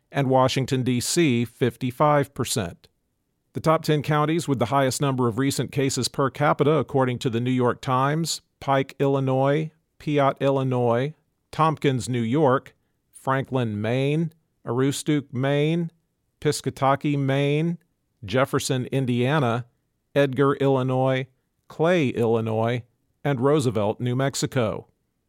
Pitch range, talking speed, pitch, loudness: 125-145 Hz, 110 wpm, 135 Hz, -23 LUFS